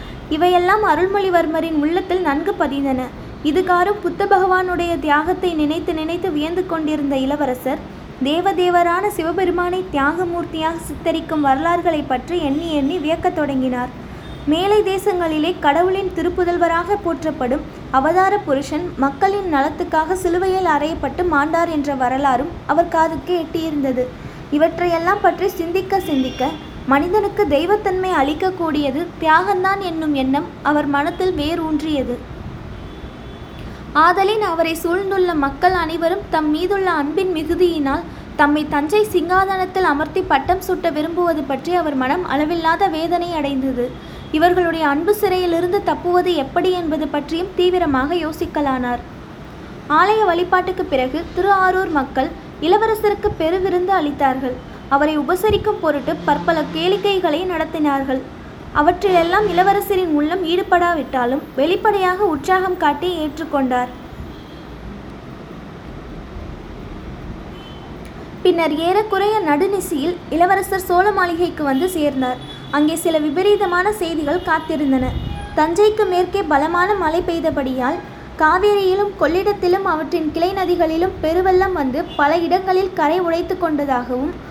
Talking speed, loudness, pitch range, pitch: 100 wpm, -18 LUFS, 300-370 Hz, 335 Hz